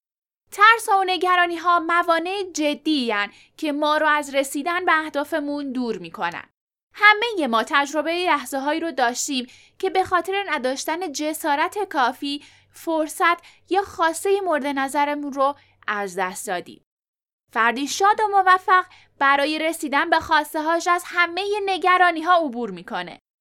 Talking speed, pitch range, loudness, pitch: 135 wpm, 280-360 Hz, -21 LUFS, 315 Hz